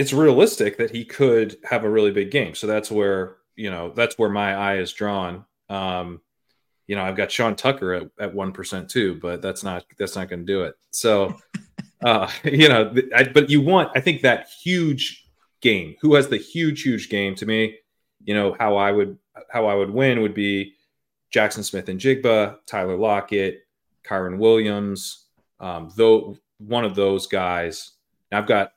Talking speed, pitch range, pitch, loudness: 185 wpm, 95-120 Hz, 105 Hz, -21 LUFS